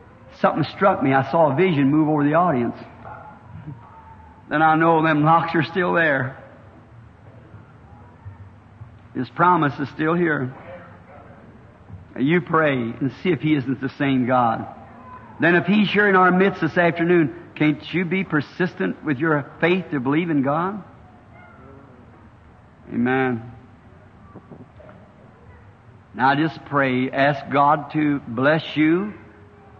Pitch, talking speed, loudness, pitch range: 135 Hz, 130 wpm, -20 LUFS, 115-160 Hz